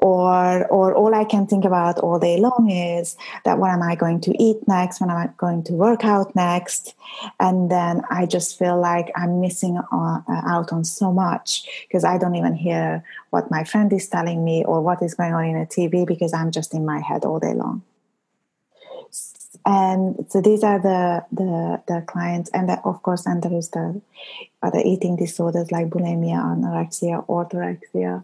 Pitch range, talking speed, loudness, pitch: 170-190 Hz, 195 wpm, -20 LUFS, 175 Hz